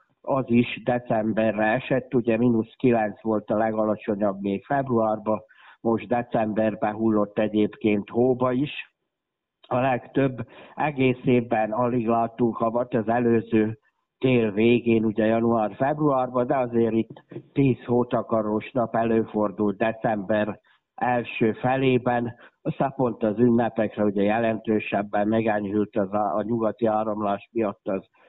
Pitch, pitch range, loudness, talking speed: 115 Hz, 110-125 Hz, -24 LUFS, 115 wpm